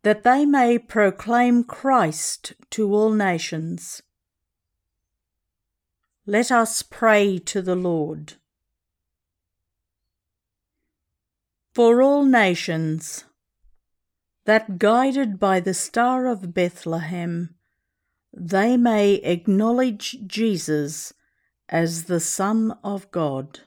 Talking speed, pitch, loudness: 85 wpm, 180 Hz, -21 LUFS